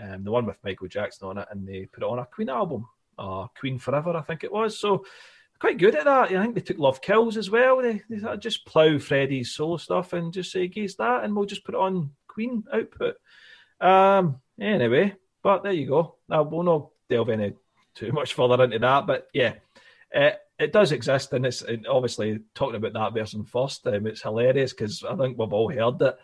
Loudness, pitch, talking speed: -24 LUFS, 155 Hz, 225 wpm